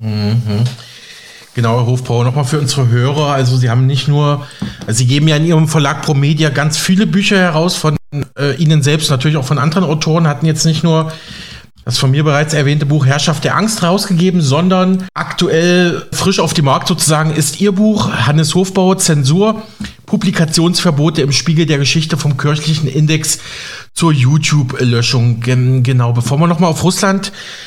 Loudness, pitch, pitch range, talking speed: -12 LUFS, 155 Hz, 140-170 Hz, 170 wpm